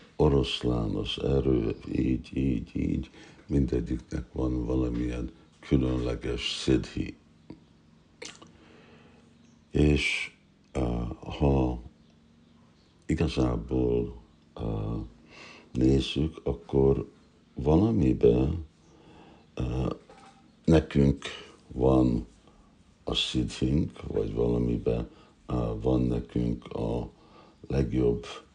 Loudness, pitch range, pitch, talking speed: -28 LUFS, 60-80 Hz, 65 Hz, 55 wpm